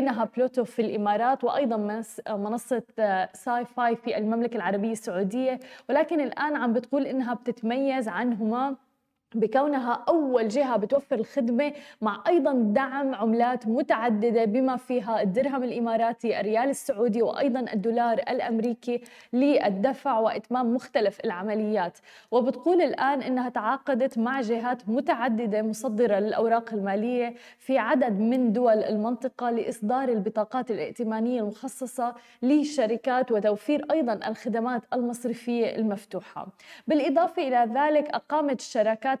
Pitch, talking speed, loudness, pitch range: 240 Hz, 110 wpm, -26 LUFS, 225-265 Hz